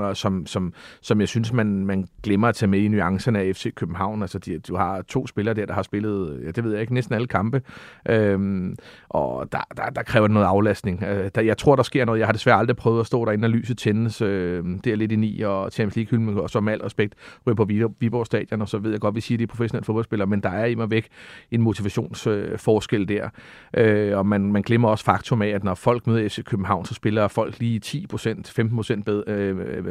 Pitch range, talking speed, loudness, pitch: 100-115 Hz, 240 wpm, -23 LUFS, 110 Hz